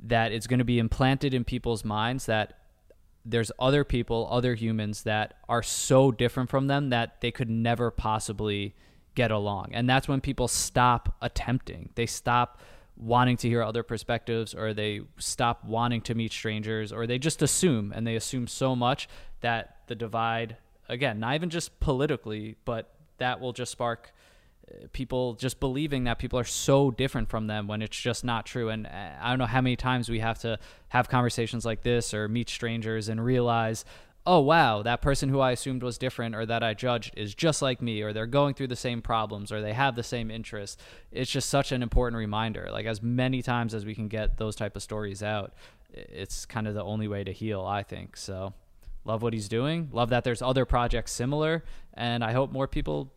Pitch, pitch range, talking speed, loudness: 120 Hz, 110-125 Hz, 200 wpm, -28 LUFS